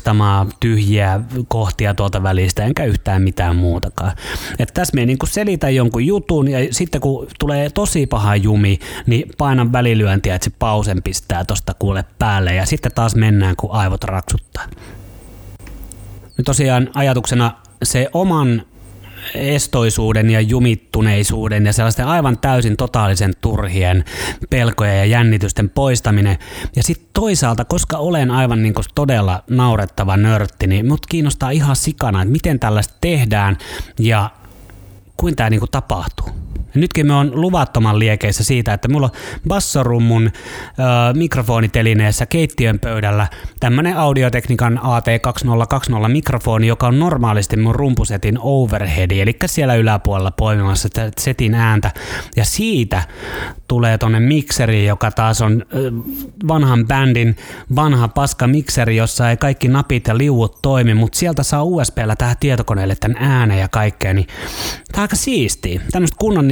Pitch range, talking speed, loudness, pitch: 105-135 Hz, 135 wpm, -16 LUFS, 115 Hz